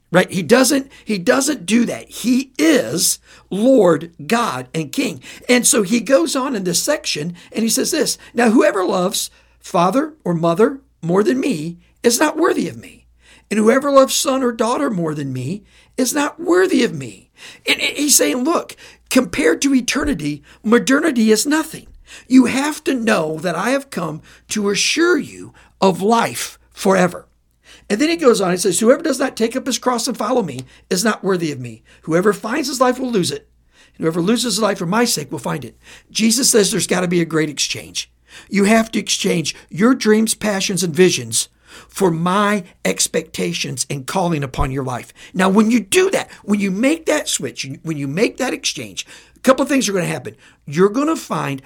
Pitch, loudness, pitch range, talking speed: 215 Hz, -17 LUFS, 175-260 Hz, 195 wpm